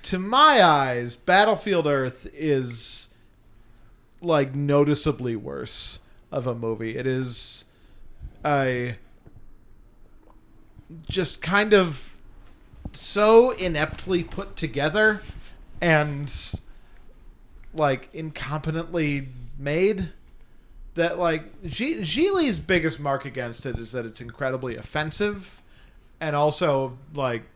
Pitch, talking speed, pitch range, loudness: 145 Hz, 90 wpm, 125-170 Hz, -24 LUFS